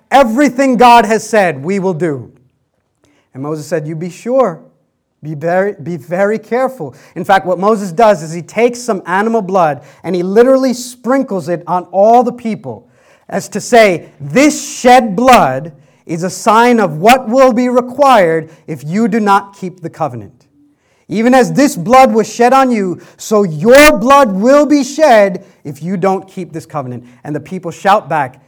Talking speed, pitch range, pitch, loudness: 175 wpm, 165-240 Hz, 200 Hz, -11 LUFS